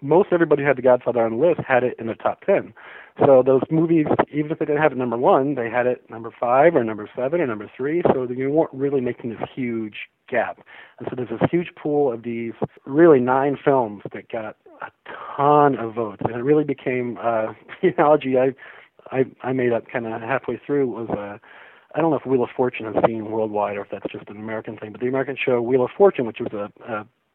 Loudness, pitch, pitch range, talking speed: -21 LUFS, 130 Hz, 115-145 Hz, 240 wpm